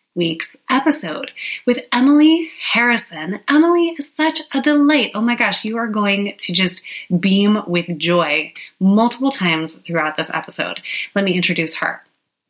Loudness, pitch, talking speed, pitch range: -16 LUFS, 205 Hz, 145 wpm, 175-270 Hz